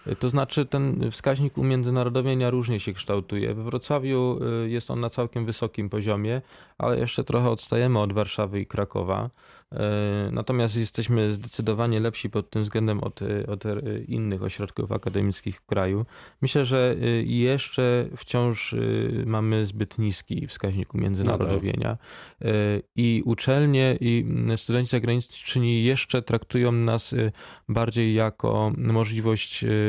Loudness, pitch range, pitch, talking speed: -25 LUFS, 105-125 Hz, 115 Hz, 115 wpm